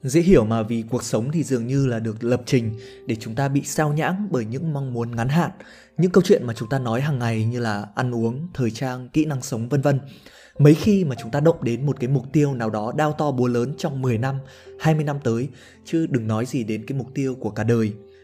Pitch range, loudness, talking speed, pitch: 115-150 Hz, -22 LUFS, 260 wpm, 130 Hz